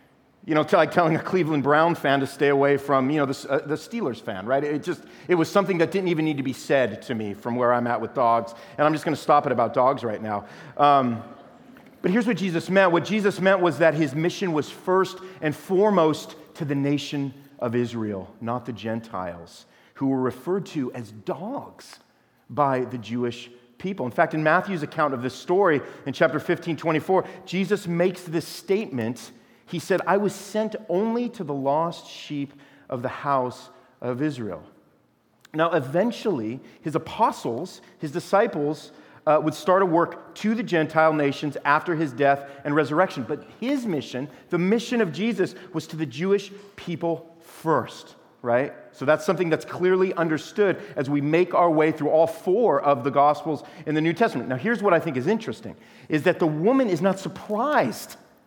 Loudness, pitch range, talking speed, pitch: -24 LUFS, 140-185 Hz, 190 wpm, 155 Hz